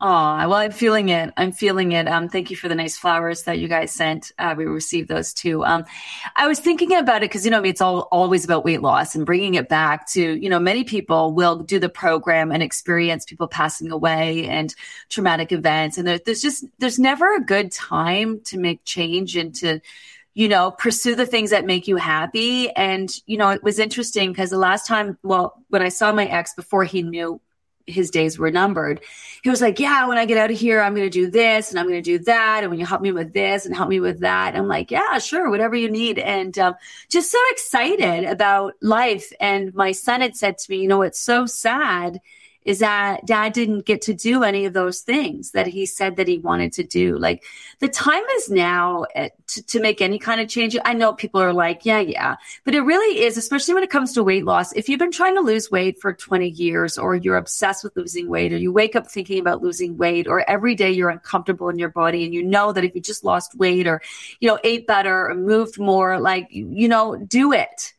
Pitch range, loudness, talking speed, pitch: 175-225 Hz, -19 LUFS, 240 wpm, 190 Hz